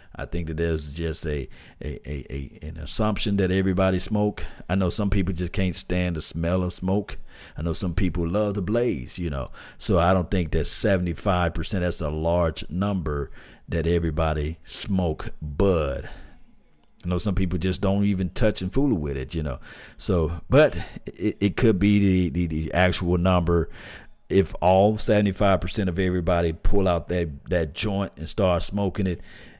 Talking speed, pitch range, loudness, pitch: 175 wpm, 80-95 Hz, -24 LUFS, 90 Hz